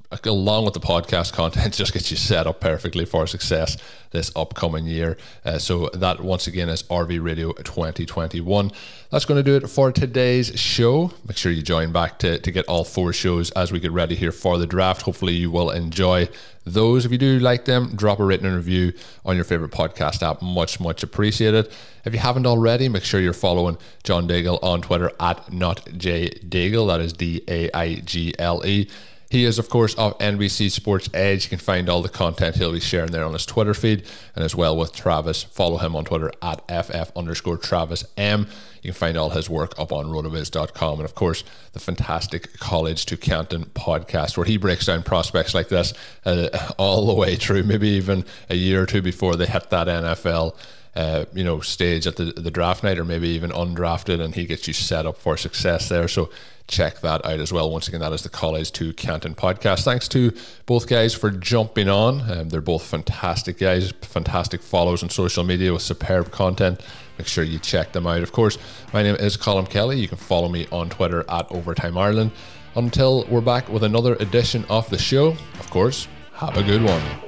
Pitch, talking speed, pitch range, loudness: 90 Hz, 210 wpm, 85-105 Hz, -21 LUFS